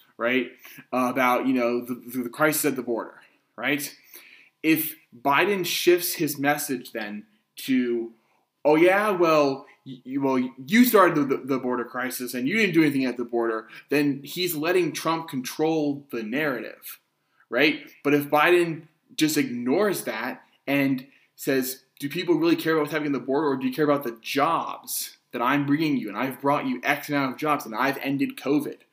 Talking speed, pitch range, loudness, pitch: 175 wpm, 125-155 Hz, -24 LUFS, 140 Hz